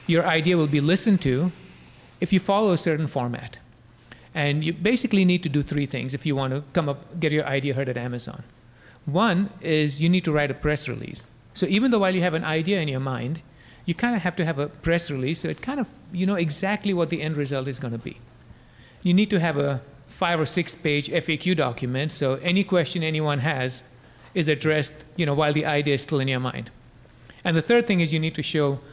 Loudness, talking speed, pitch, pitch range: -24 LUFS, 235 wpm, 155 Hz, 135-175 Hz